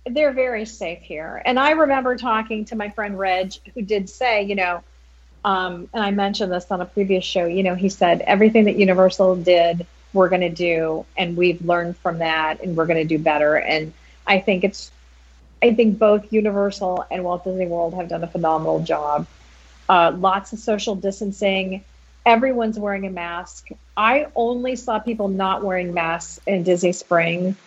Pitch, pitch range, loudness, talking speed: 190 Hz, 170-210 Hz, -20 LUFS, 185 wpm